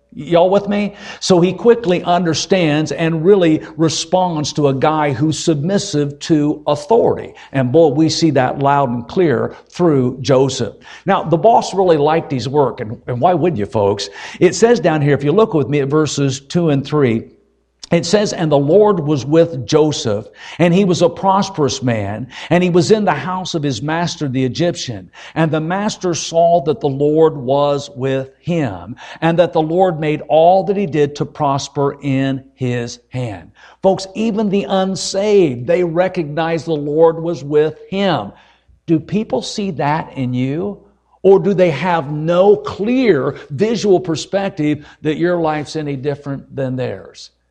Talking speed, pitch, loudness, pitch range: 170 wpm, 160 Hz, -15 LUFS, 140-180 Hz